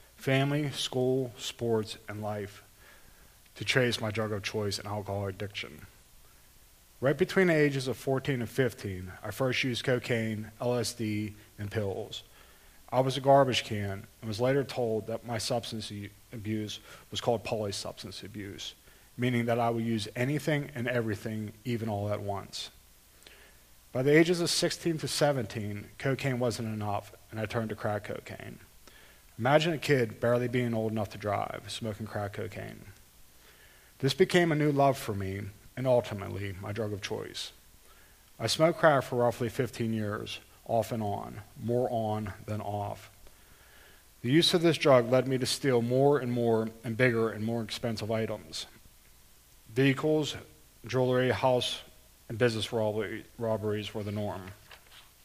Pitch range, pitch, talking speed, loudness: 105-125 Hz, 115 Hz, 150 wpm, -30 LUFS